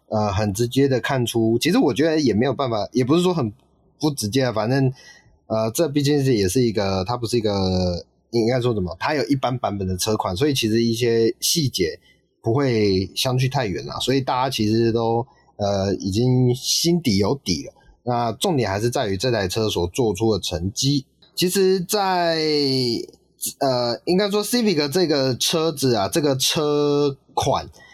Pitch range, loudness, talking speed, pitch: 110-145 Hz, -21 LUFS, 265 characters per minute, 125 Hz